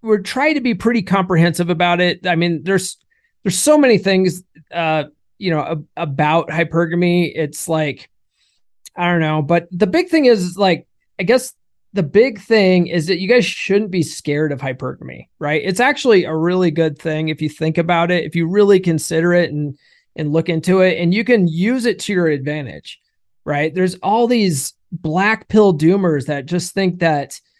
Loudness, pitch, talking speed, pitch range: -16 LUFS, 175 Hz, 190 wpm, 160-195 Hz